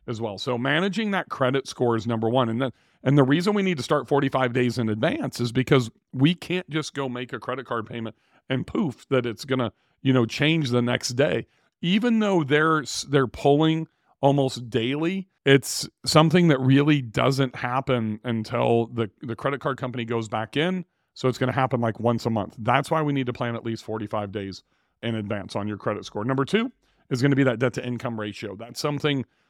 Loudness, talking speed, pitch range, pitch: -24 LUFS, 210 wpm, 115-145 Hz, 130 Hz